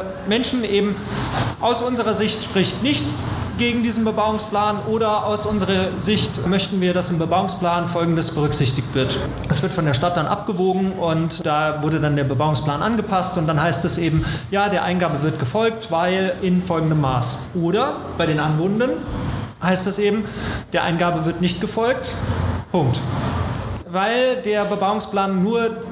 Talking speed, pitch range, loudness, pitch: 155 wpm, 160-210 Hz, -20 LUFS, 180 Hz